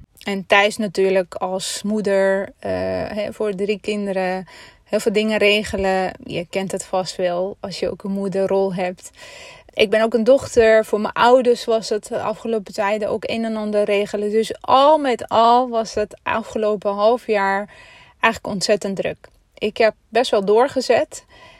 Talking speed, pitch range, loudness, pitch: 165 wpm, 195-225 Hz, -19 LUFS, 210 Hz